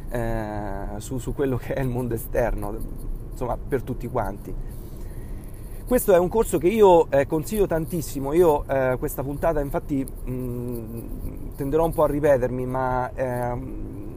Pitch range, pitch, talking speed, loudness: 115-145 Hz, 125 Hz, 150 wpm, -24 LUFS